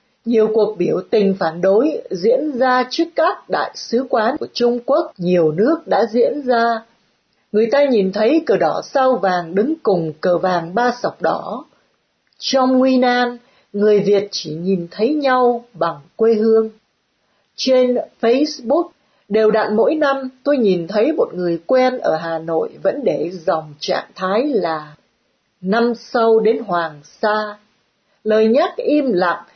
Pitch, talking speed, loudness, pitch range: 225 Hz, 160 wpm, -17 LUFS, 190-255 Hz